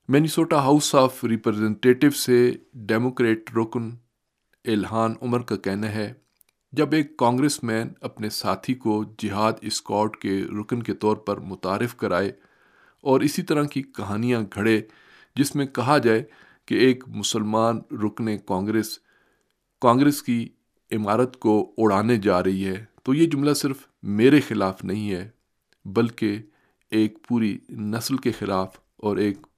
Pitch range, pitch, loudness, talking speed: 105-130 Hz, 115 Hz, -23 LUFS, 135 wpm